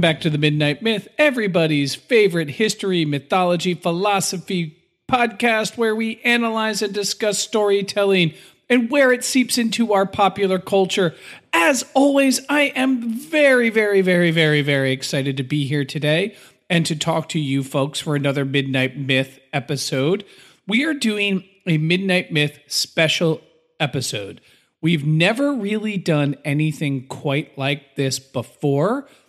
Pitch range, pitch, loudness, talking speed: 150-220 Hz, 180 Hz, -19 LUFS, 135 wpm